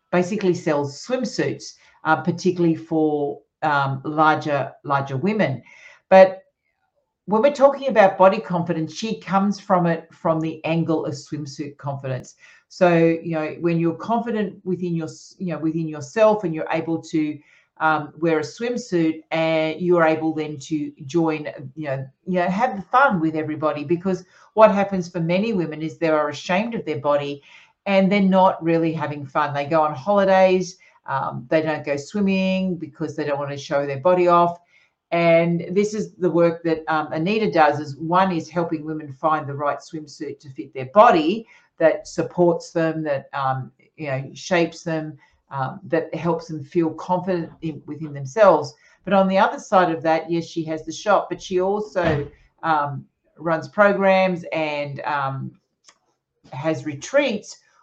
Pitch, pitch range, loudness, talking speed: 165 Hz, 155-185 Hz, -21 LUFS, 165 wpm